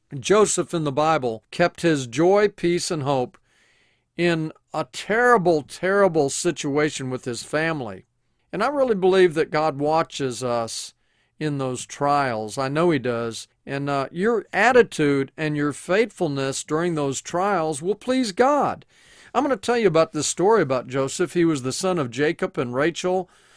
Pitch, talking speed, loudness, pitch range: 155 Hz, 165 wpm, -22 LUFS, 135-185 Hz